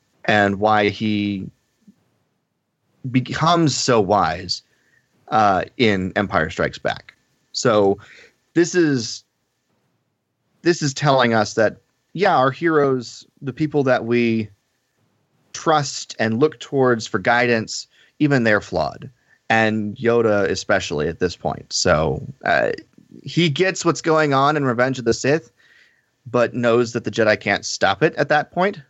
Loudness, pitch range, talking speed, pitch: -19 LUFS, 110-150 Hz, 135 wpm, 125 Hz